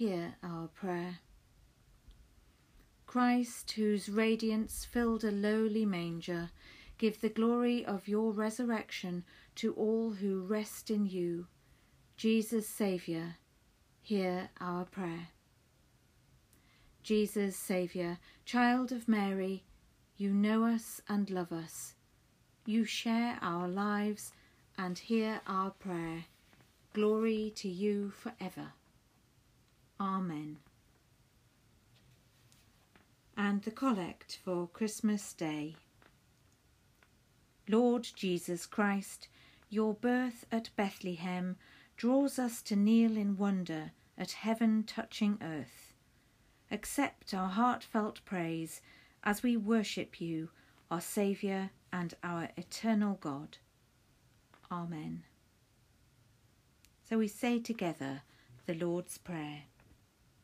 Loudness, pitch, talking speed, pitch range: -35 LUFS, 195 Hz, 95 wpm, 165-220 Hz